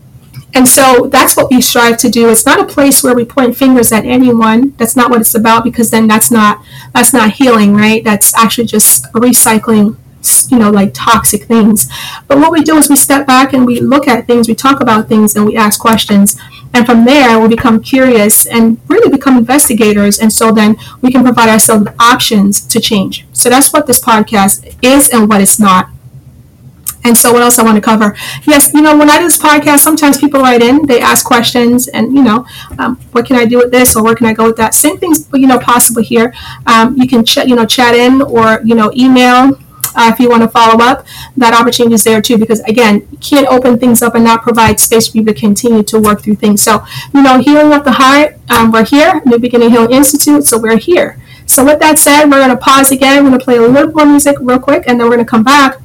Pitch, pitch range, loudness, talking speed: 240 Hz, 225-265 Hz, -6 LUFS, 240 wpm